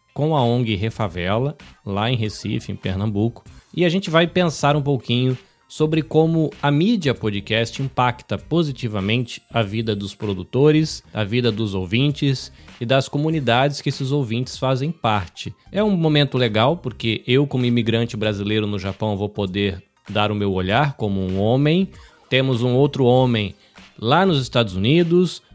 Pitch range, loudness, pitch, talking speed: 105-145 Hz, -20 LUFS, 120 Hz, 155 wpm